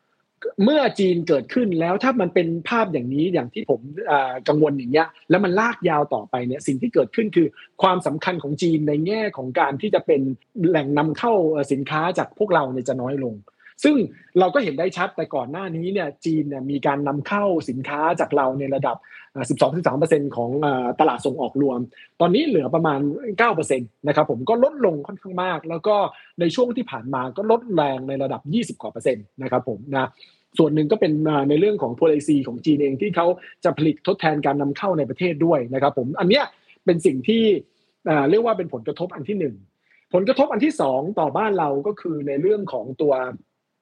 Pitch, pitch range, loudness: 155 Hz, 140-190 Hz, -21 LUFS